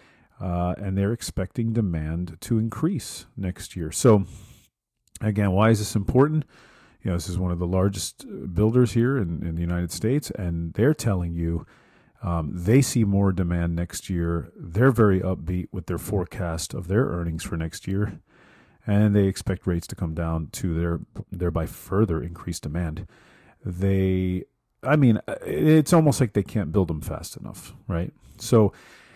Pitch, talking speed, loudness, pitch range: 95 Hz, 165 wpm, -24 LUFS, 85-110 Hz